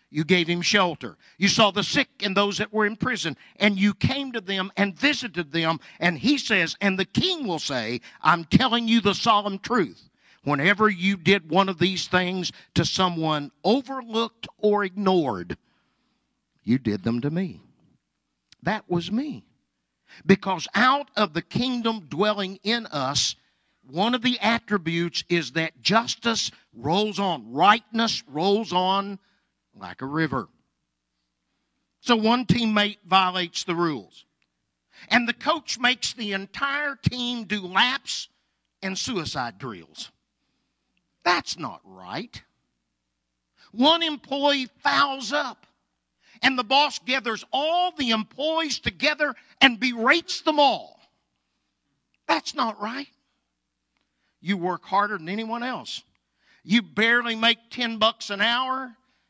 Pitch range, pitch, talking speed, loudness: 175-240 Hz, 205 Hz, 135 wpm, -23 LUFS